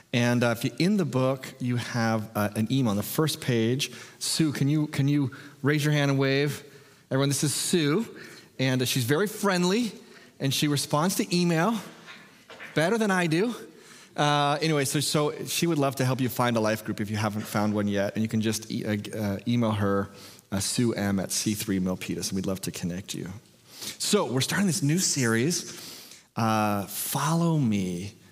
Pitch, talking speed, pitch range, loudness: 130 Hz, 200 wpm, 110-150 Hz, -26 LUFS